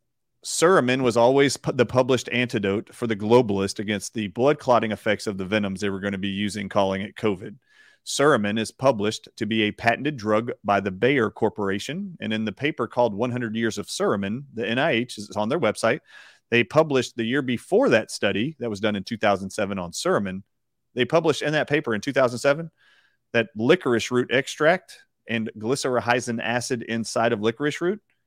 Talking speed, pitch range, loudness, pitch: 185 wpm, 105-125 Hz, -23 LUFS, 115 Hz